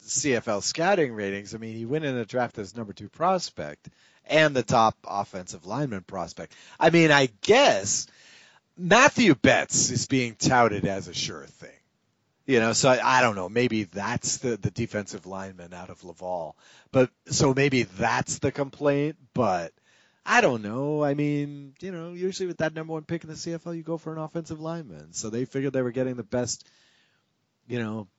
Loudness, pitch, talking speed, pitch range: -25 LUFS, 125 Hz, 185 wpm, 110-150 Hz